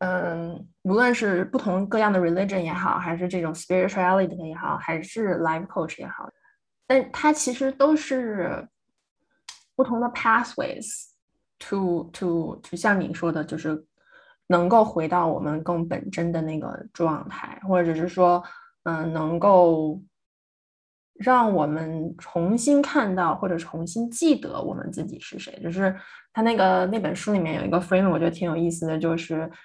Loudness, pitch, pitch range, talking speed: -24 LUFS, 180 Hz, 165-225 Hz, 300 characters per minute